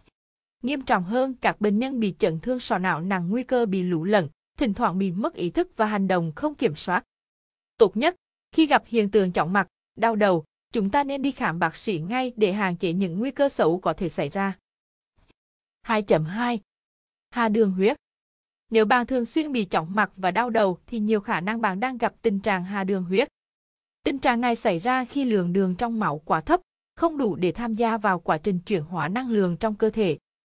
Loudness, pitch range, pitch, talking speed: -24 LUFS, 190-245 Hz, 215 Hz, 220 wpm